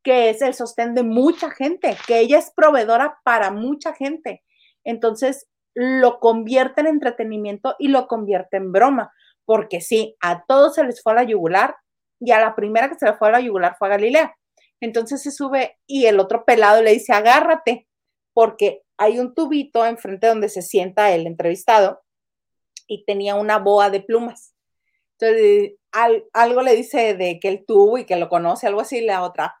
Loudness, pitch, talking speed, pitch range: -18 LUFS, 230 Hz, 185 wpm, 210-265 Hz